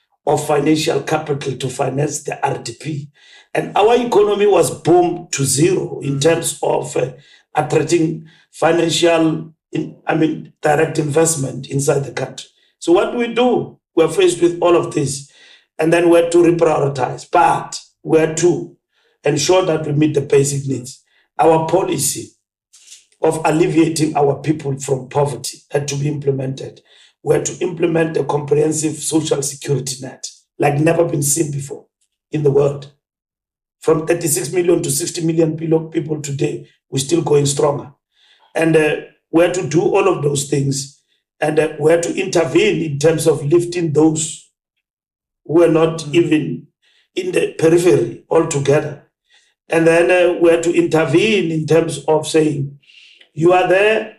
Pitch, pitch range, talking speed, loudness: 160 Hz, 145-170 Hz, 150 wpm, -16 LUFS